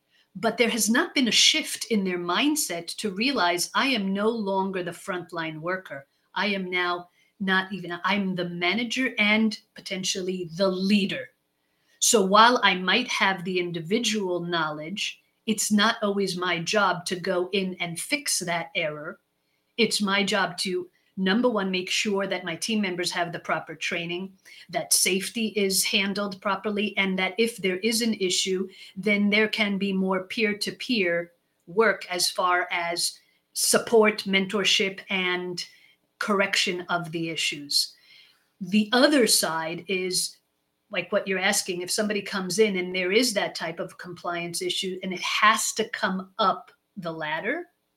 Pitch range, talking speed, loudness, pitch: 180-210 Hz, 160 wpm, -24 LUFS, 190 Hz